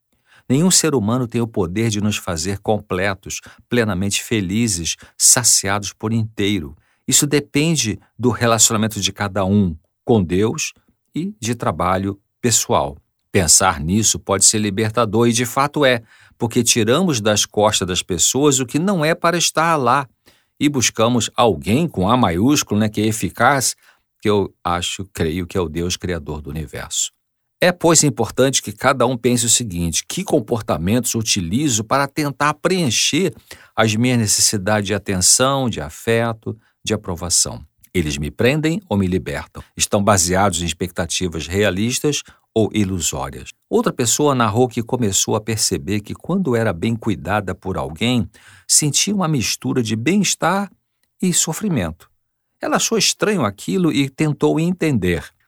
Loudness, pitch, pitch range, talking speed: -17 LUFS, 110 Hz, 95-130 Hz, 150 wpm